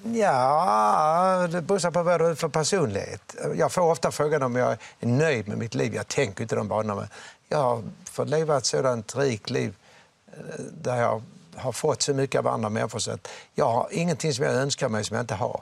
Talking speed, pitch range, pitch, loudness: 205 wpm, 125-170 Hz, 155 Hz, -25 LUFS